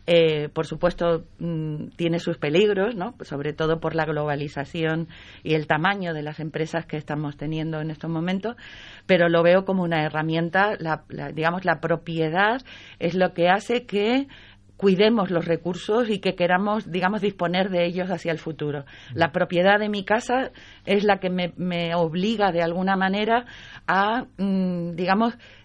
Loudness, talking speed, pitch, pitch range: -23 LUFS, 165 wpm, 170 Hz, 160-195 Hz